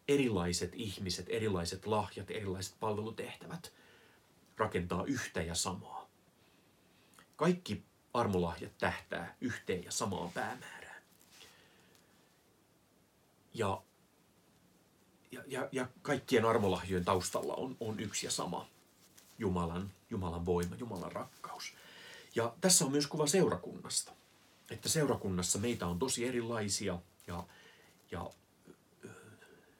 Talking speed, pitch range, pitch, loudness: 95 wpm, 90-115 Hz, 95 Hz, -36 LUFS